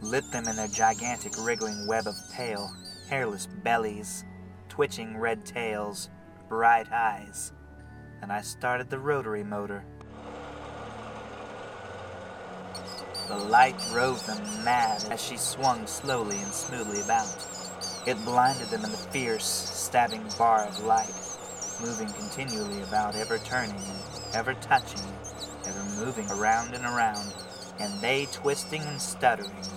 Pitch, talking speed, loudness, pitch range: 105 Hz, 125 wpm, -29 LUFS, 100-120 Hz